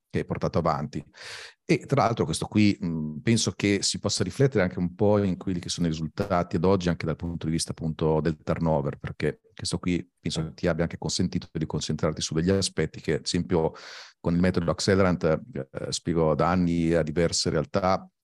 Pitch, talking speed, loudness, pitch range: 85 Hz, 205 wpm, -26 LUFS, 80-95 Hz